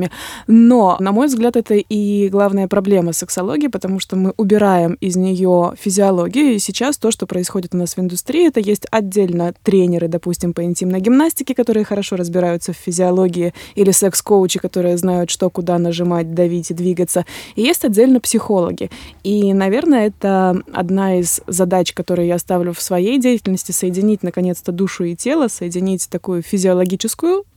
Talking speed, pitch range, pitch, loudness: 155 wpm, 180-210 Hz, 190 Hz, -16 LUFS